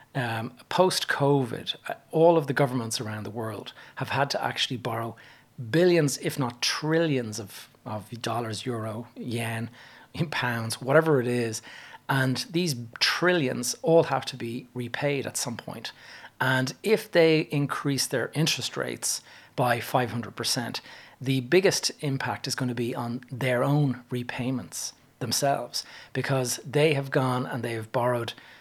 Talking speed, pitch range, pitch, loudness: 145 wpm, 120-140 Hz, 130 Hz, -27 LUFS